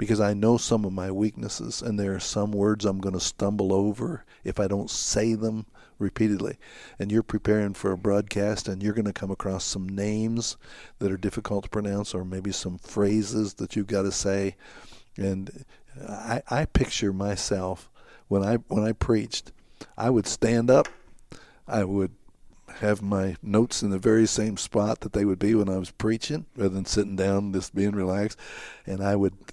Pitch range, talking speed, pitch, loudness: 95-110 Hz, 190 wpm, 100 Hz, -26 LUFS